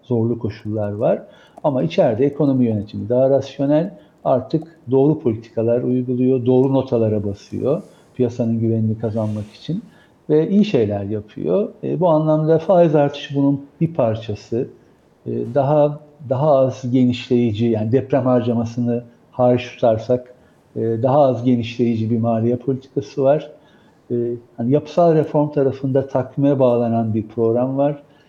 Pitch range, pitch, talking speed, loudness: 115-145 Hz, 125 Hz, 125 wpm, -19 LUFS